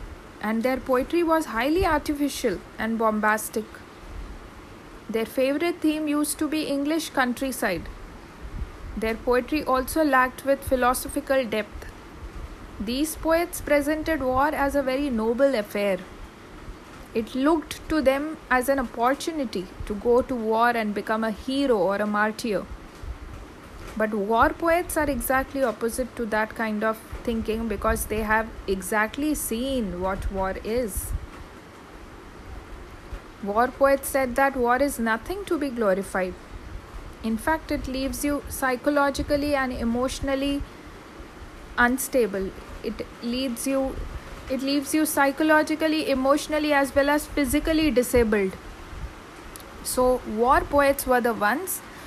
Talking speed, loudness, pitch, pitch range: 125 wpm, -24 LUFS, 255 Hz, 220-285 Hz